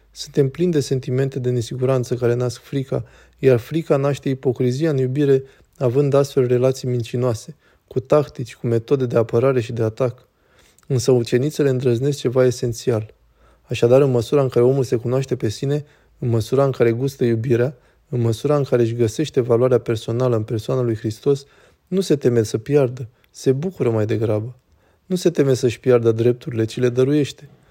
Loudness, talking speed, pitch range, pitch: -20 LUFS, 170 wpm, 120-140 Hz, 125 Hz